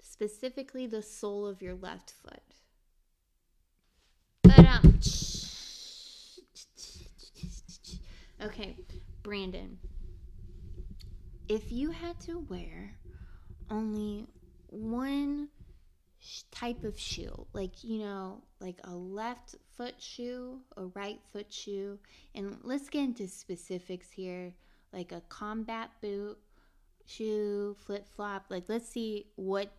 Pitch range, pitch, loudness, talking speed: 185-235 Hz, 205 Hz, -29 LUFS, 105 wpm